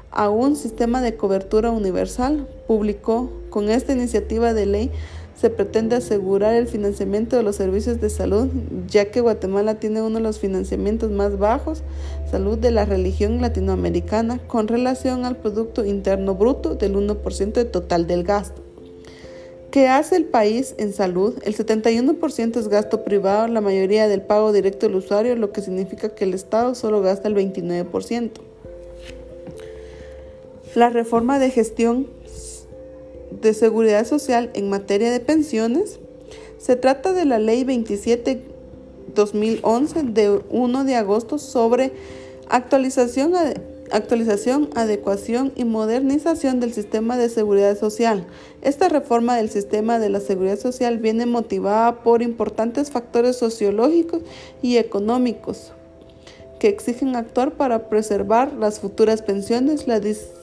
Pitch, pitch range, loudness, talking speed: 220 Hz, 200-245 Hz, -20 LUFS, 135 wpm